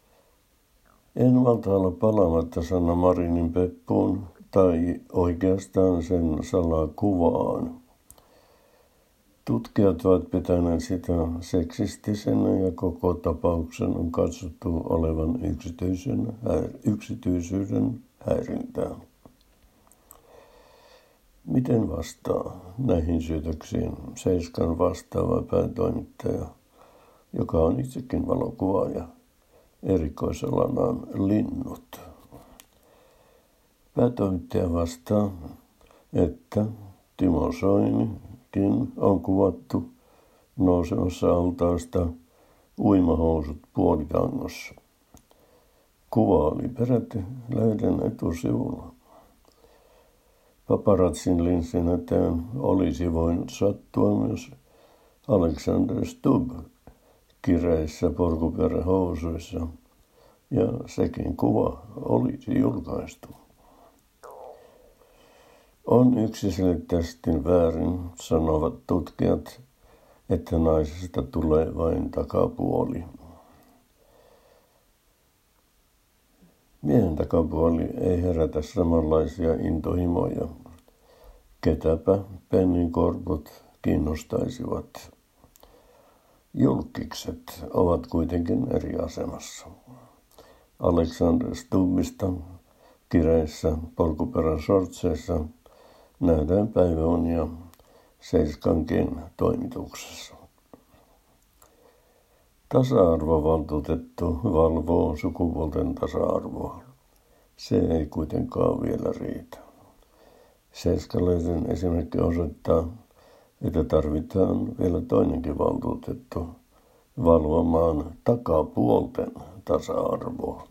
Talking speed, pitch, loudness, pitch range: 60 wpm, 90 Hz, -25 LUFS, 80-95 Hz